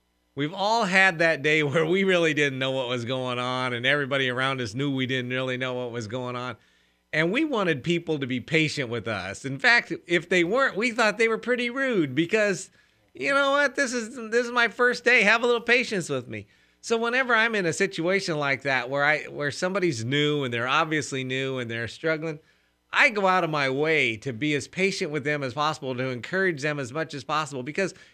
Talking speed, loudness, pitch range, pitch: 225 wpm, -24 LUFS, 130-195 Hz, 155 Hz